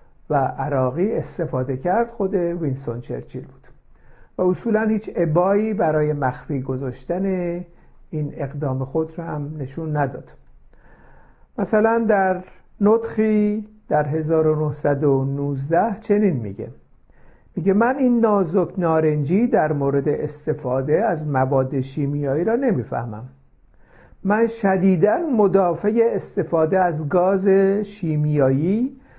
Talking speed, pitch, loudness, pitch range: 100 wpm, 165 Hz, -21 LUFS, 140-200 Hz